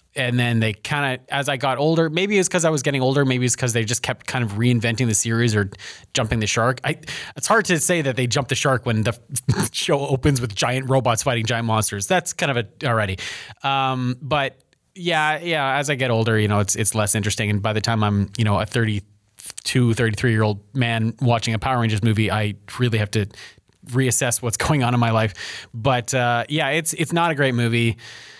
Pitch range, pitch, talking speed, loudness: 110-140 Hz, 120 Hz, 230 wpm, -20 LUFS